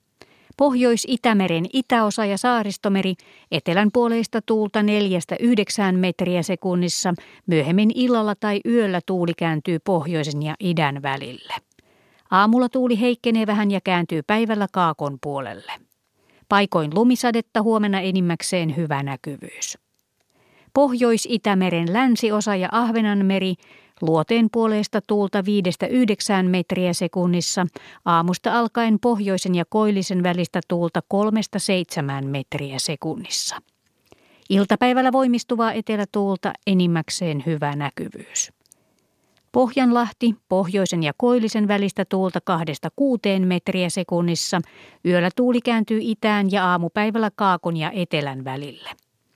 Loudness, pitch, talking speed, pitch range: -21 LUFS, 195 Hz, 95 wpm, 175-225 Hz